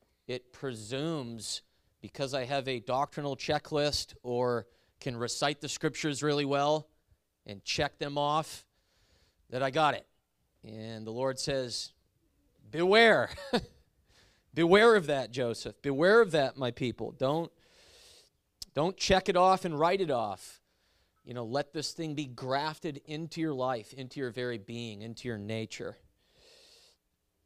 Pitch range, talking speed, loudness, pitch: 115-155 Hz, 140 wpm, -31 LUFS, 135 Hz